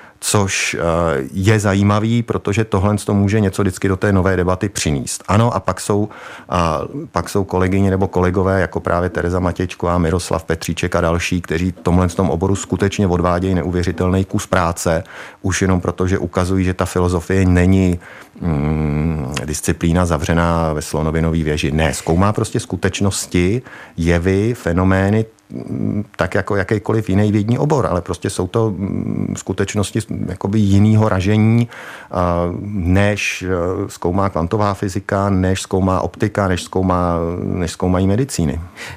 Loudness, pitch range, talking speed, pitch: -17 LUFS, 85-100 Hz, 140 wpm, 95 Hz